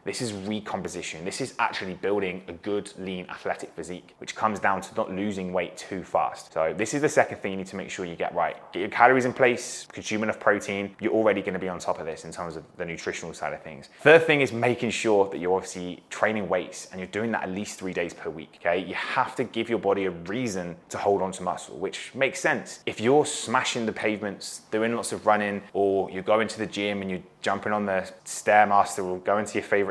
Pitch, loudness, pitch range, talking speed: 100 Hz, -26 LUFS, 95-110 Hz, 245 wpm